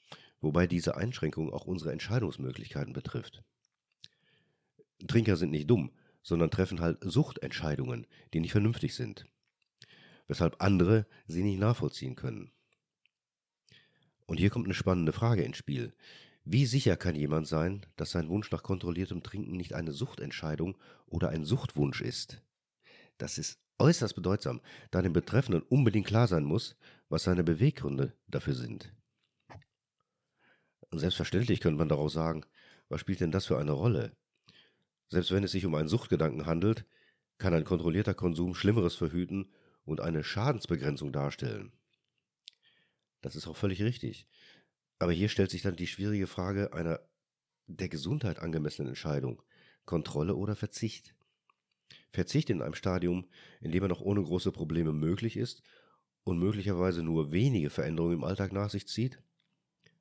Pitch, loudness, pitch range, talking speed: 90 Hz, -32 LUFS, 80-105 Hz, 140 wpm